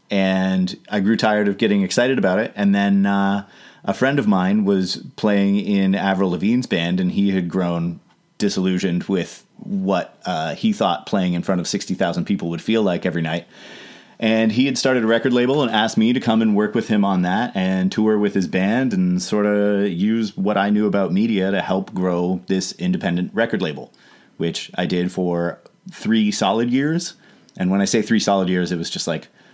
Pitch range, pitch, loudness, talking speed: 95-125 Hz, 100 Hz, -20 LUFS, 205 wpm